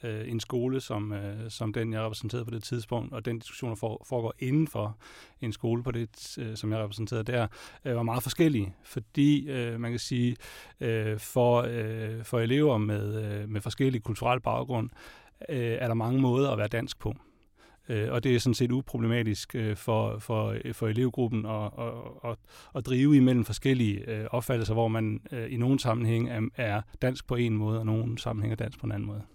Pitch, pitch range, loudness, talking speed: 115 Hz, 110-125 Hz, -30 LUFS, 175 wpm